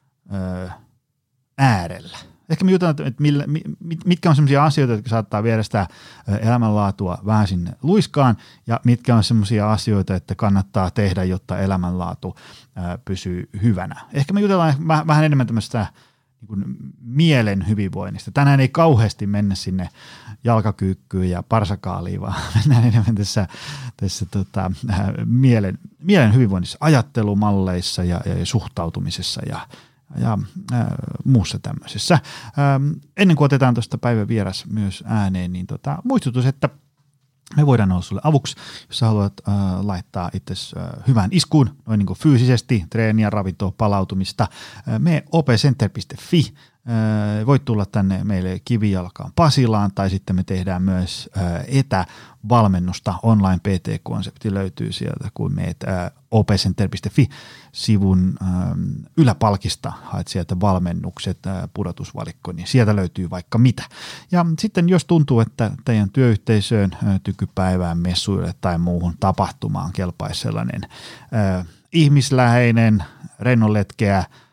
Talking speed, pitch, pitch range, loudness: 120 wpm, 110 Hz, 95-135 Hz, -19 LUFS